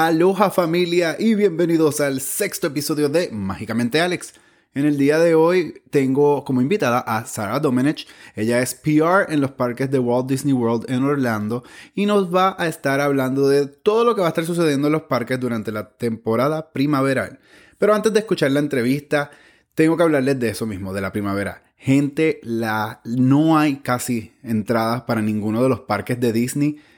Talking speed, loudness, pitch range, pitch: 180 wpm, -20 LUFS, 120-160 Hz, 140 Hz